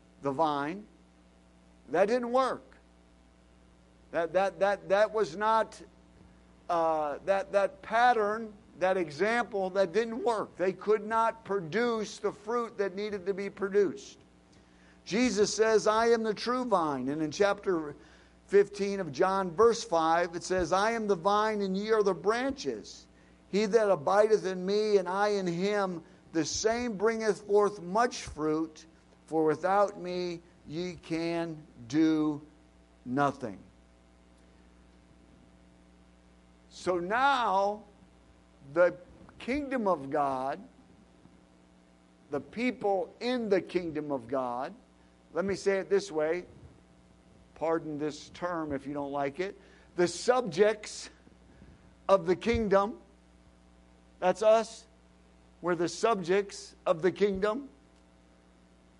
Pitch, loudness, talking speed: 180 Hz, -30 LUFS, 120 wpm